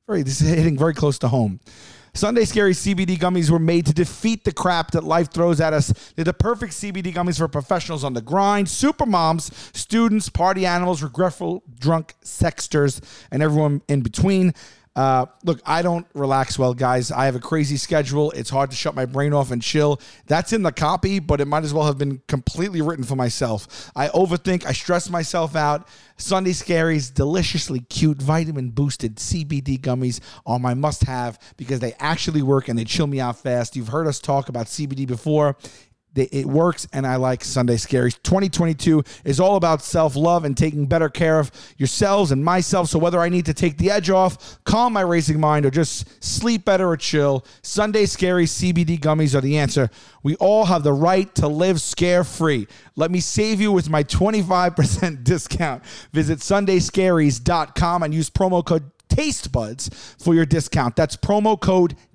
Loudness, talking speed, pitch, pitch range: -20 LUFS, 185 wpm, 155 Hz, 135-175 Hz